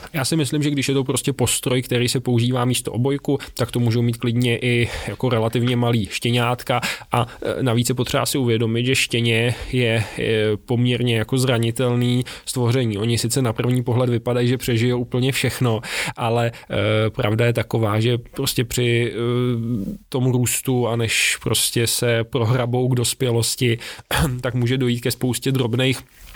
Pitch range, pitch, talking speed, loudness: 115-130 Hz, 120 Hz, 155 wpm, -20 LUFS